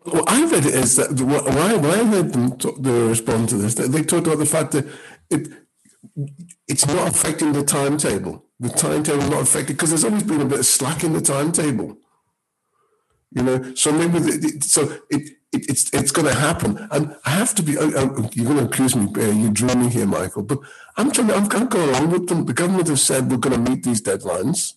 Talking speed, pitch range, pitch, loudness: 220 wpm, 130-175 Hz, 150 Hz, -18 LUFS